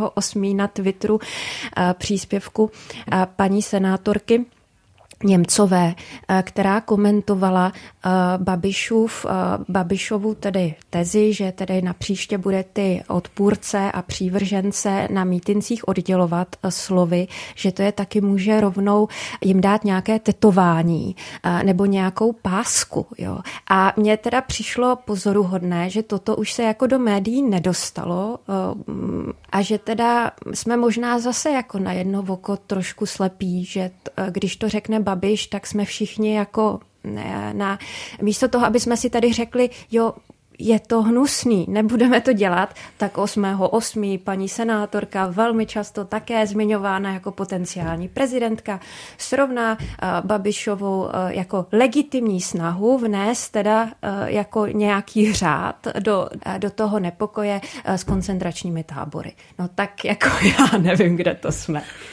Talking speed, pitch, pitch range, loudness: 125 wpm, 200 Hz, 190-220 Hz, -21 LUFS